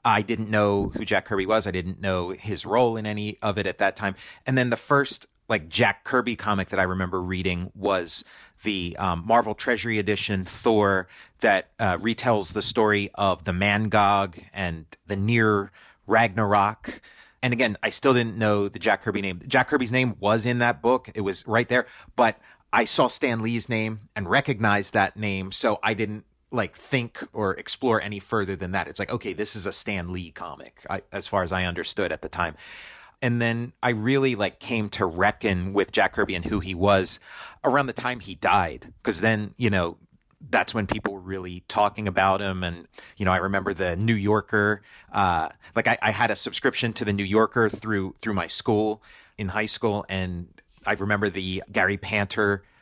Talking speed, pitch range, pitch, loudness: 200 wpm, 95-115 Hz, 105 Hz, -24 LUFS